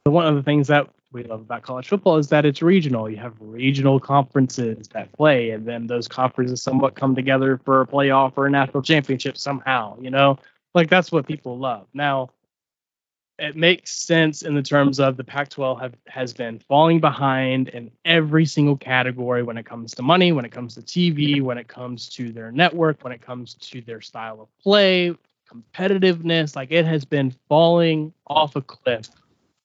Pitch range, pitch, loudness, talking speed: 125-155 Hz, 135 Hz, -20 LUFS, 190 wpm